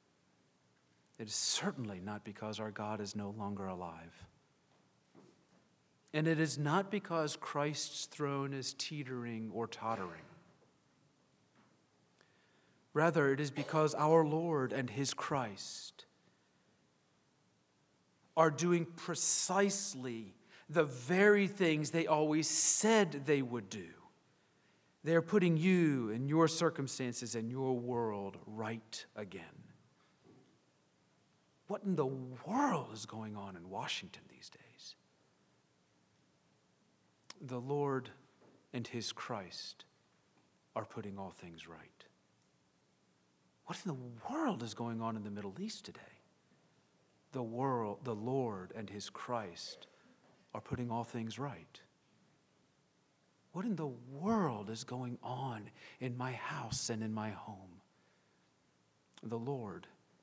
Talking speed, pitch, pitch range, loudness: 115 wpm, 125 Hz, 105-155 Hz, -36 LUFS